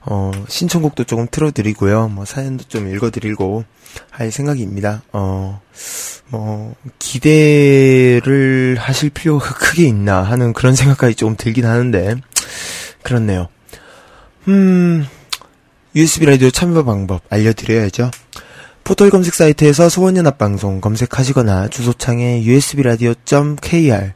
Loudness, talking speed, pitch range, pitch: -14 LUFS, 285 characters per minute, 110-145 Hz, 125 Hz